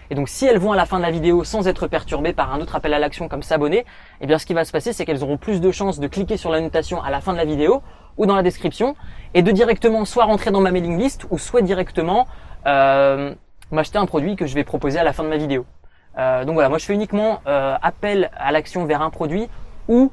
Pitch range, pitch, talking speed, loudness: 150-200 Hz, 170 Hz, 270 wpm, -19 LUFS